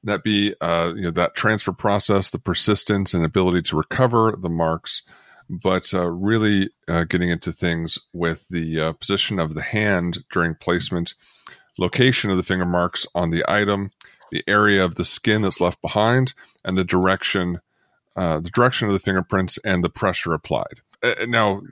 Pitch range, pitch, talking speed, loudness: 85-105 Hz, 95 Hz, 175 wpm, -21 LUFS